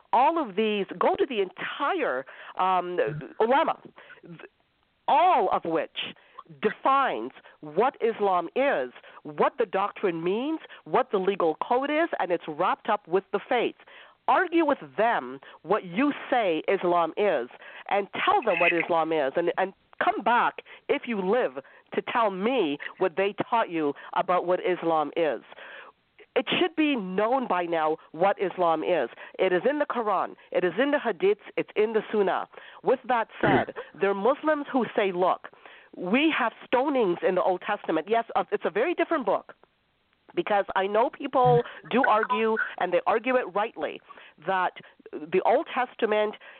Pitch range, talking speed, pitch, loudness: 180-275 Hz, 160 wpm, 215 Hz, -26 LUFS